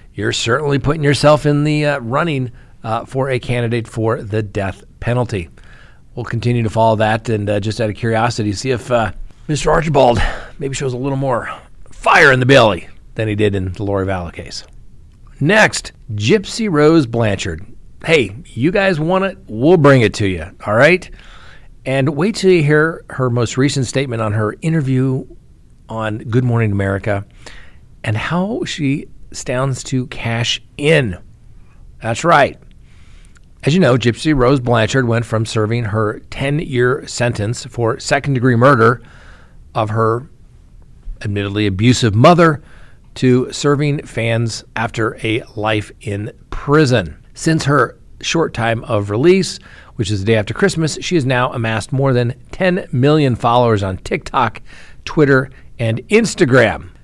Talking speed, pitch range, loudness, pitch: 150 wpm, 110-140 Hz, -15 LUFS, 120 Hz